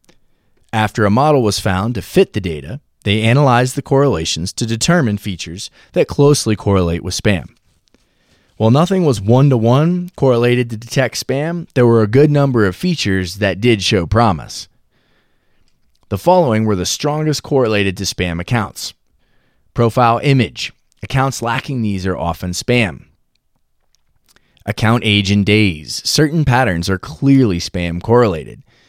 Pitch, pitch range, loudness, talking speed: 115 Hz, 100-135 Hz, -15 LUFS, 145 wpm